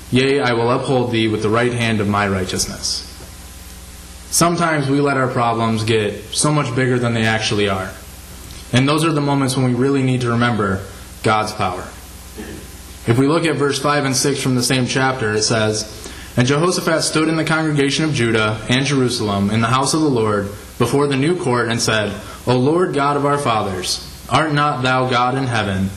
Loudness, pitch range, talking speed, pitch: -17 LUFS, 105-140 Hz, 200 wpm, 120 Hz